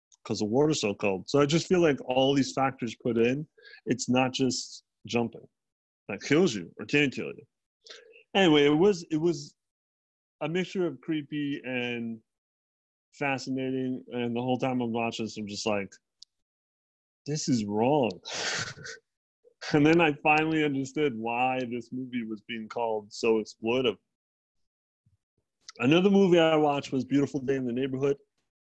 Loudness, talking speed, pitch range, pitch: -27 LUFS, 150 wpm, 110-150 Hz, 130 Hz